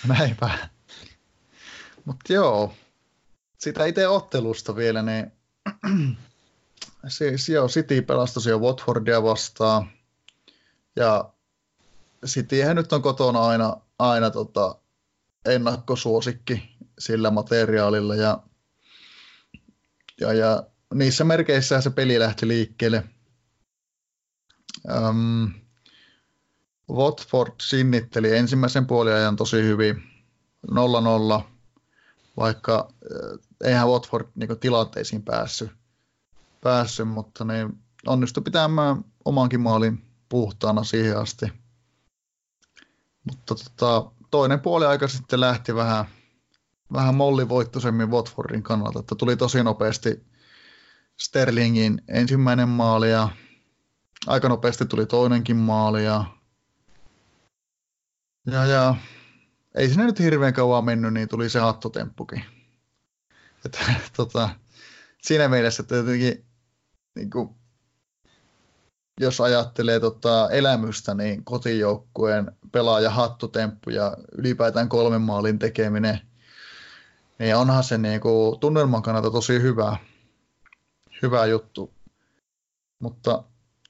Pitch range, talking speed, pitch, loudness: 110-125 Hz, 90 wpm, 120 Hz, -22 LUFS